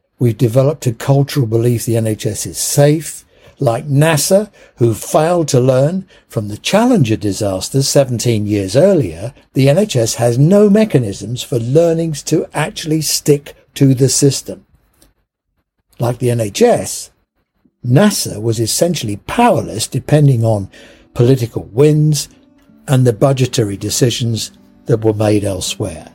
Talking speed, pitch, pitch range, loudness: 125 wpm, 130 Hz, 115-150 Hz, -14 LUFS